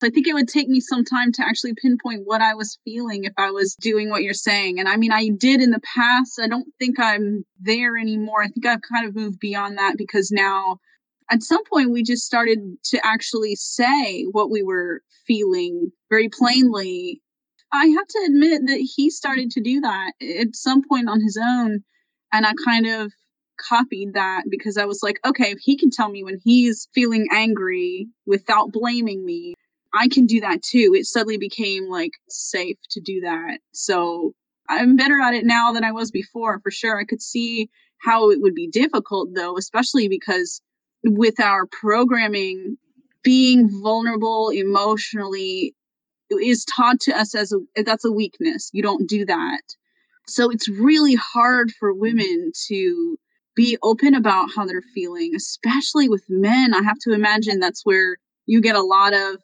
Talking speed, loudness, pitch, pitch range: 185 wpm, -19 LUFS, 230 Hz, 210-260 Hz